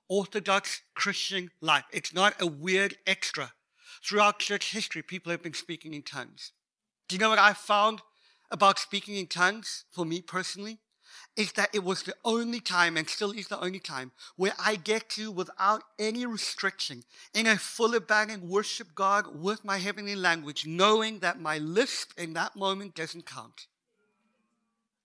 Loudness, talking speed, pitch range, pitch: -28 LUFS, 165 wpm, 175-215 Hz, 200 Hz